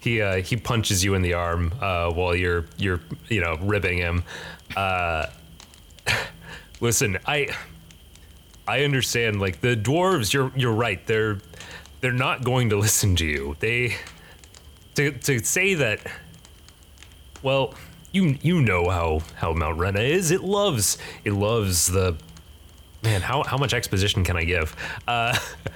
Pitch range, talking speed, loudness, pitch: 85-120 Hz, 145 wpm, -23 LUFS, 100 Hz